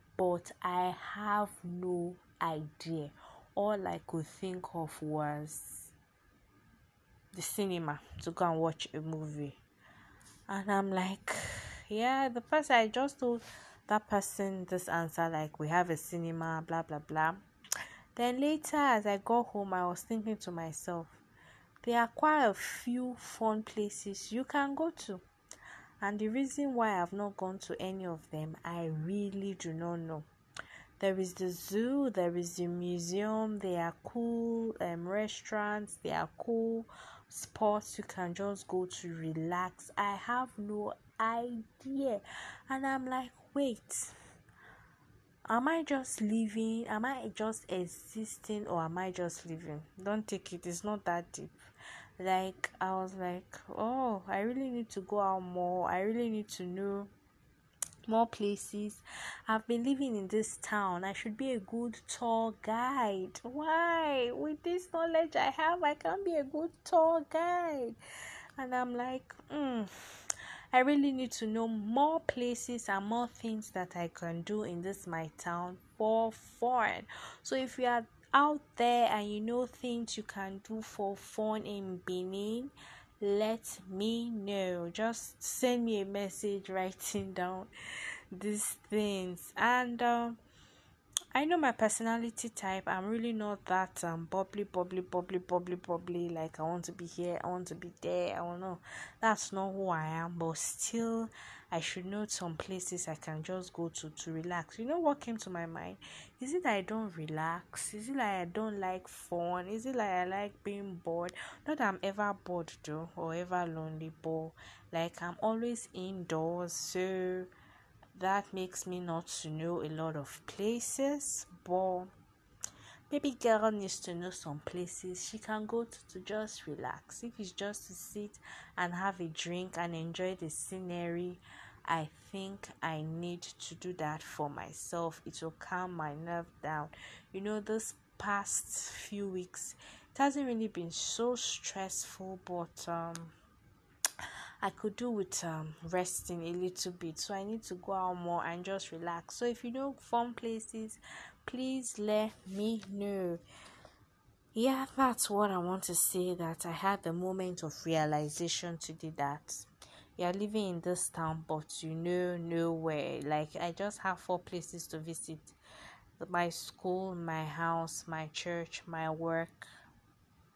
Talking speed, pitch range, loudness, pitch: 160 wpm, 170-225 Hz, -36 LUFS, 190 Hz